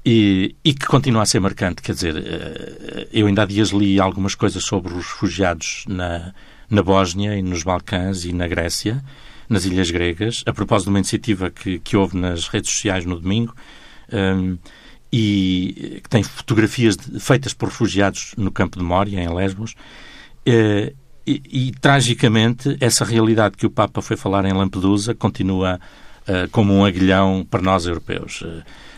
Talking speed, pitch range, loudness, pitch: 160 wpm, 95-115 Hz, -19 LUFS, 100 Hz